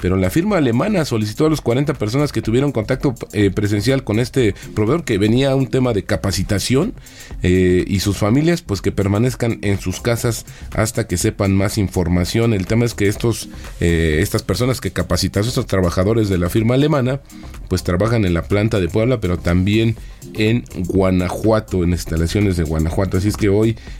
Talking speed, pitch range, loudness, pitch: 185 wpm, 95-120 Hz, -18 LUFS, 105 Hz